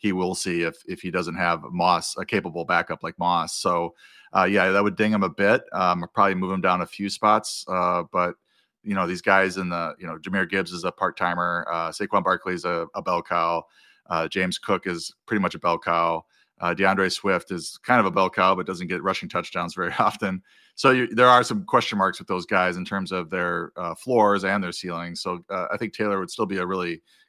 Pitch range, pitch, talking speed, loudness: 85-95 Hz, 95 Hz, 240 wpm, -24 LUFS